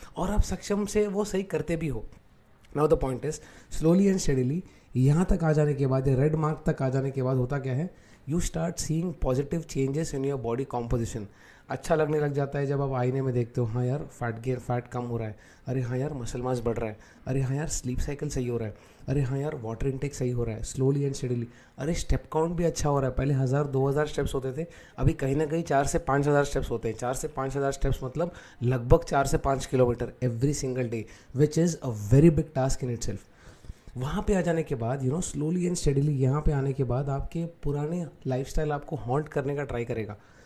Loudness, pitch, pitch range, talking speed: -28 LUFS, 135 Hz, 125-155 Hz, 245 wpm